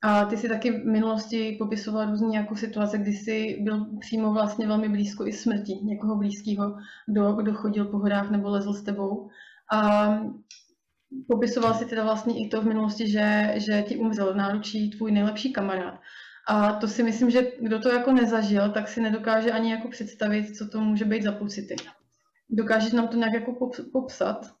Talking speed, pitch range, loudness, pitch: 185 wpm, 210-225 Hz, -26 LUFS, 215 Hz